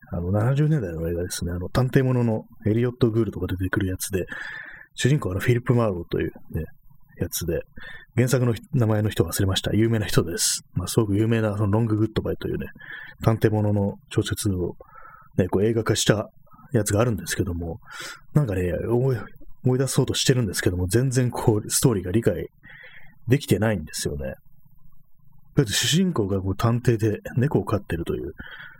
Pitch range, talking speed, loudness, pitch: 100-130 Hz, 375 characters per minute, -24 LUFS, 115 Hz